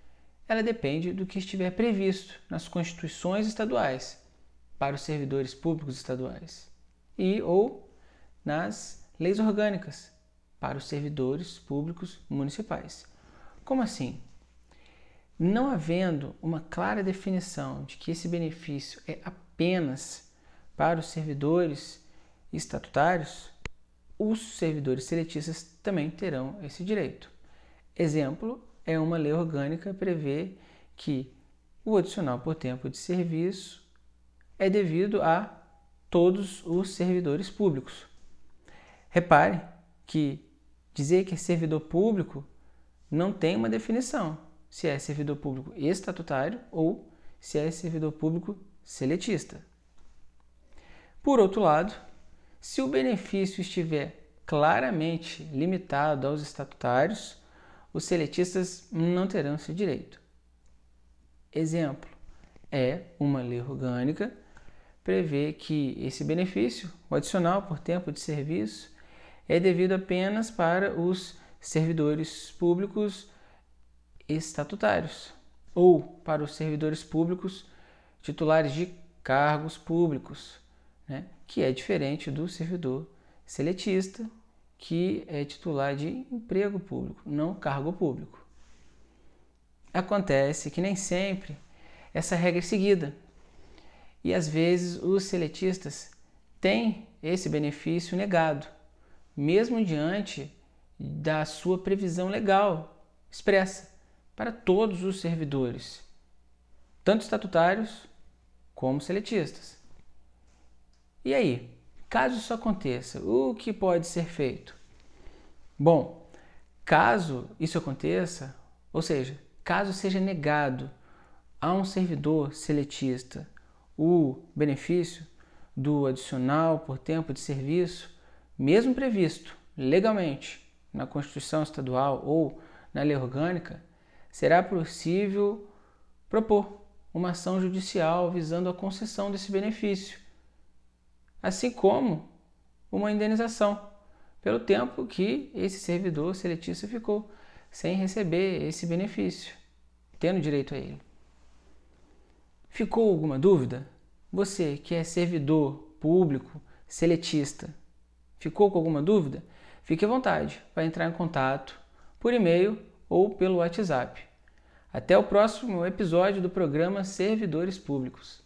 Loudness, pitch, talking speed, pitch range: -29 LUFS, 160 Hz, 105 wpm, 135-185 Hz